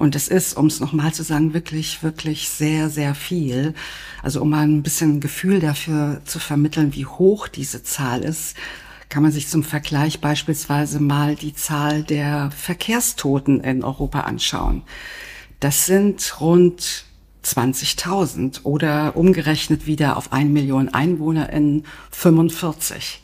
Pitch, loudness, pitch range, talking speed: 150 Hz, -19 LUFS, 145-160 Hz, 140 wpm